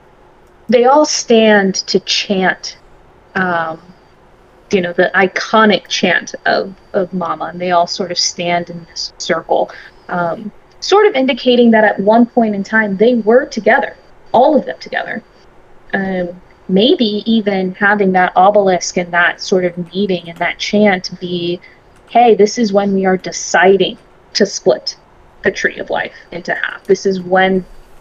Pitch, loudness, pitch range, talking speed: 195 Hz, -13 LUFS, 180-220 Hz, 155 wpm